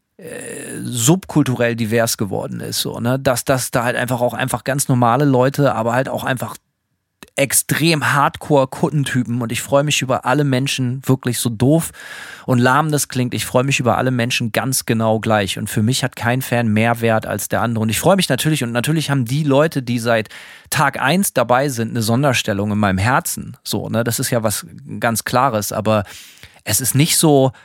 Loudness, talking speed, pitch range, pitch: -17 LUFS, 200 wpm, 115-140 Hz, 125 Hz